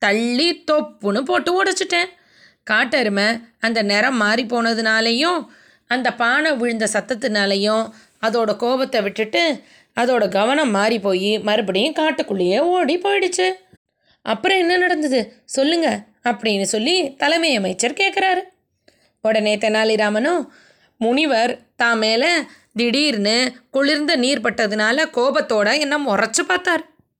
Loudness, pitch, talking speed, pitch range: -18 LUFS, 240 Hz, 100 wpm, 220-315 Hz